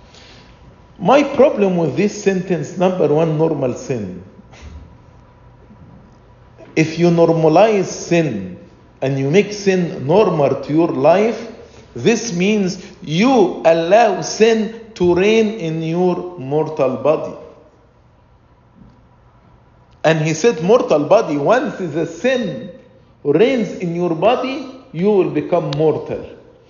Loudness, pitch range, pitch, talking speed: -16 LUFS, 155-215 Hz, 180 Hz, 110 wpm